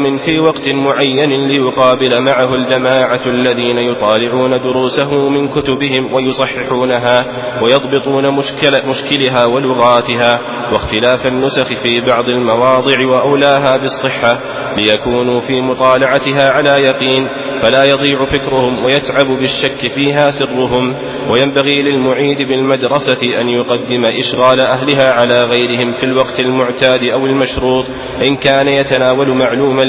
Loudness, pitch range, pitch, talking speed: -11 LUFS, 125-135 Hz, 130 Hz, 105 wpm